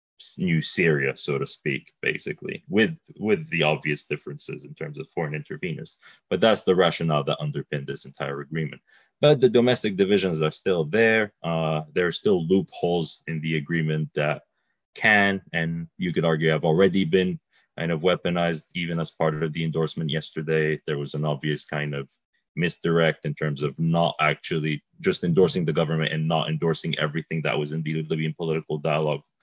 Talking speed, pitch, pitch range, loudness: 175 wpm, 80 Hz, 75-85 Hz, -24 LUFS